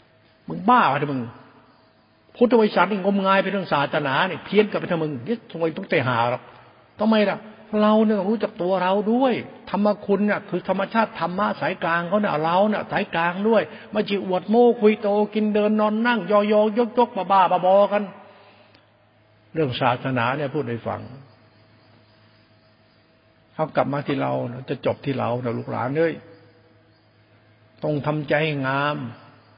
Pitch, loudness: 165 Hz, -22 LUFS